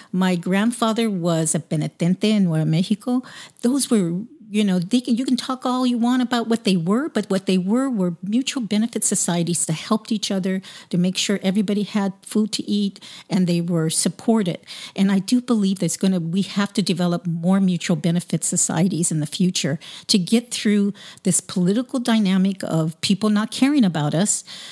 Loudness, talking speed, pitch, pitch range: -21 LUFS, 190 wpm, 195 Hz, 180-225 Hz